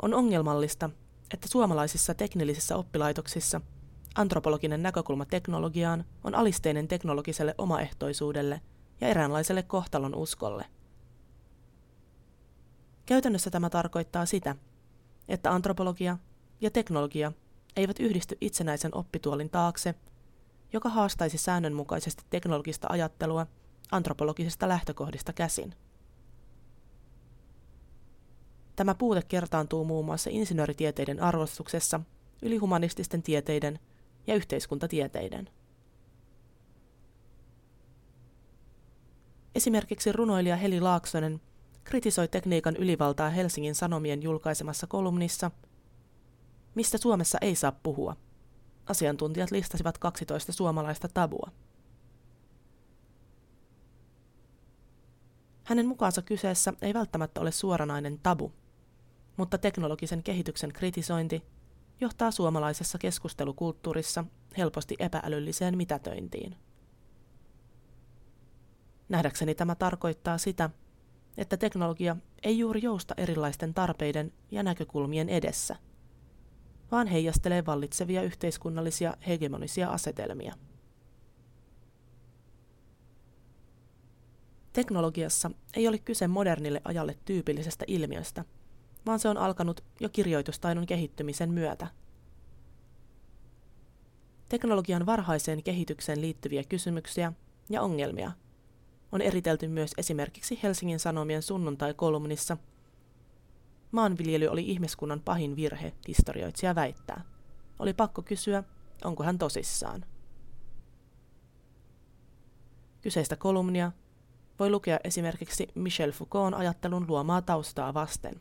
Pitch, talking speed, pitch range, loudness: 160 Hz, 85 wpm, 130-180 Hz, -31 LUFS